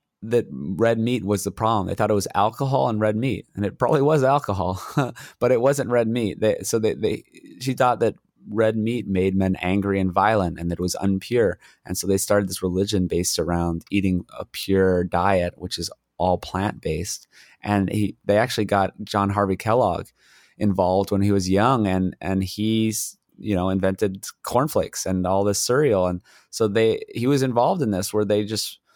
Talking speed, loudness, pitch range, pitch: 195 wpm, -22 LUFS, 95-110 Hz, 100 Hz